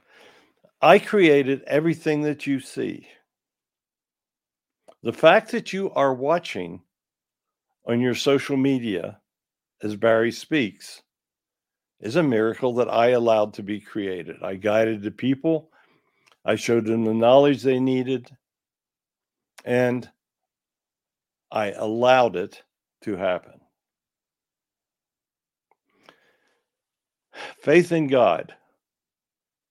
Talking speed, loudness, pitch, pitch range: 95 wpm, -22 LUFS, 125 Hz, 110-140 Hz